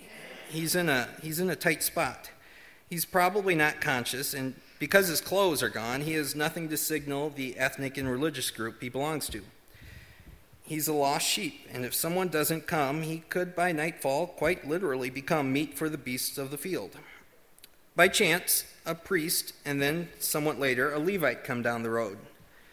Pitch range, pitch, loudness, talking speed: 135-165 Hz, 150 Hz, -29 LUFS, 180 wpm